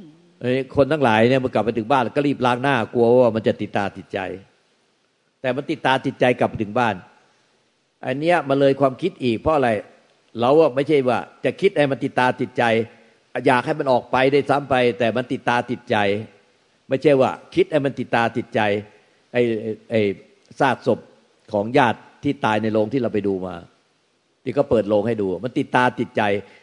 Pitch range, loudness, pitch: 110-135 Hz, -20 LUFS, 125 Hz